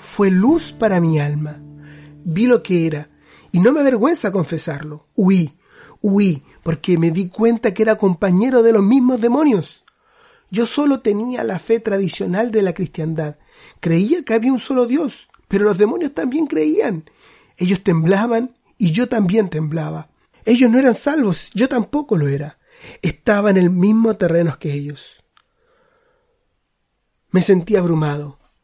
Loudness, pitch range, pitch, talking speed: -17 LUFS, 165-240 Hz, 200 Hz, 150 wpm